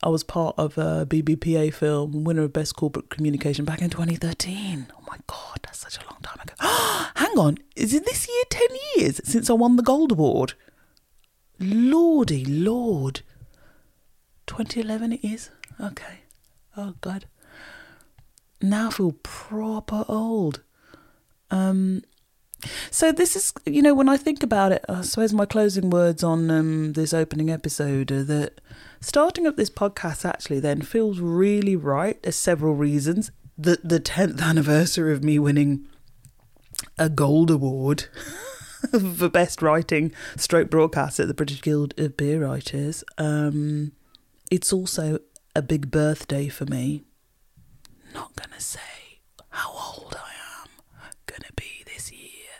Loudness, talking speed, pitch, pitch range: -23 LUFS, 150 wpm, 160 Hz, 150-205 Hz